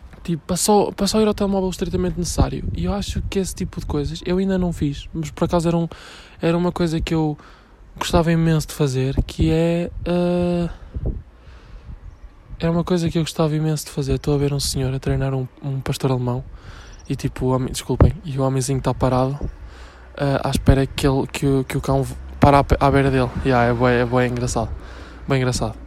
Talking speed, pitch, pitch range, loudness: 205 wpm, 140 Hz, 125-170 Hz, -21 LUFS